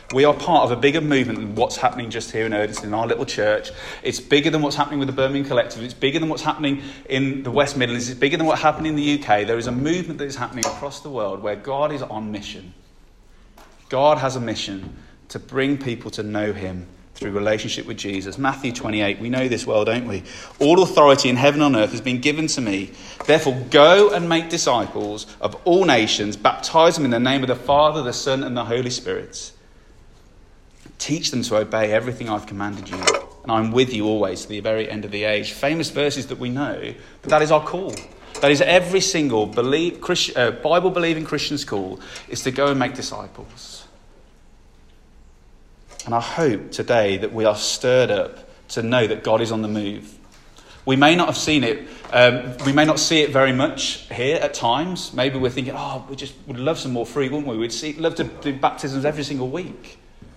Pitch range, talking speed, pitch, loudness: 110-150 Hz, 215 wpm, 130 Hz, -20 LUFS